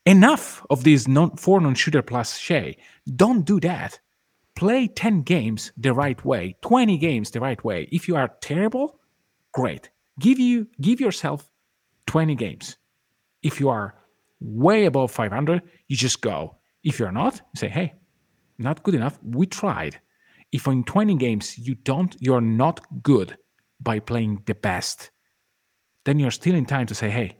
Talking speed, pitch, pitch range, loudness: 160 wpm, 145 Hz, 120-180 Hz, -22 LUFS